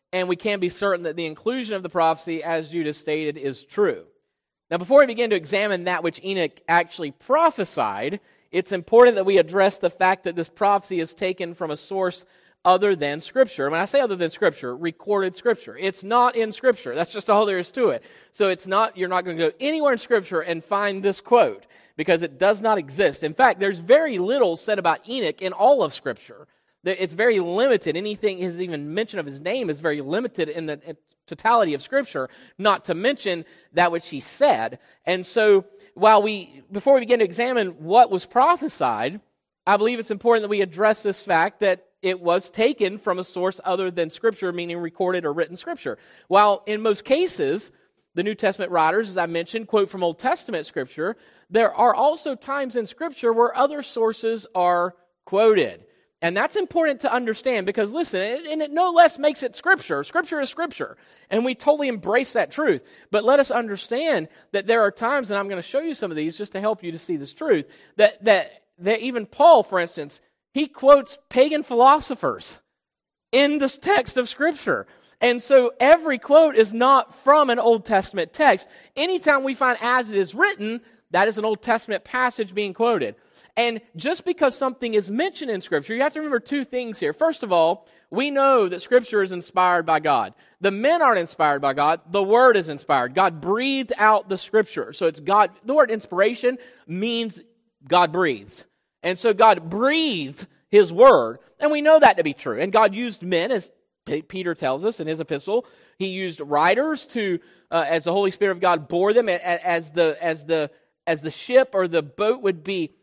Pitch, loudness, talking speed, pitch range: 205 Hz, -21 LUFS, 200 wpm, 175-250 Hz